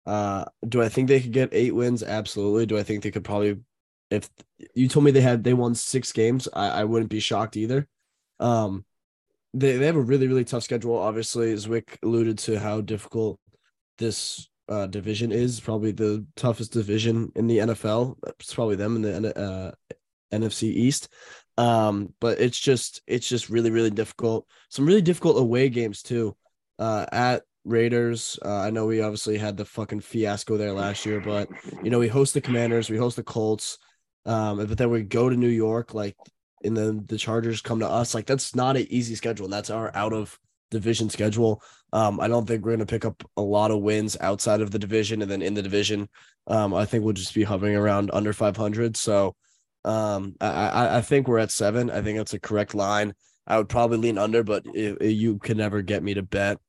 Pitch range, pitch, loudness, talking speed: 105-120 Hz, 110 Hz, -25 LUFS, 210 wpm